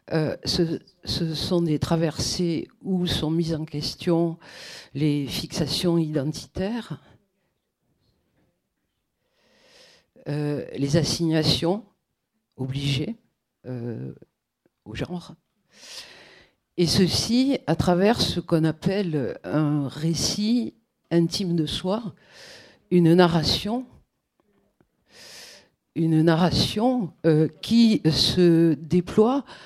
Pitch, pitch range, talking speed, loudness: 165 Hz, 150-185 Hz, 85 wpm, -23 LUFS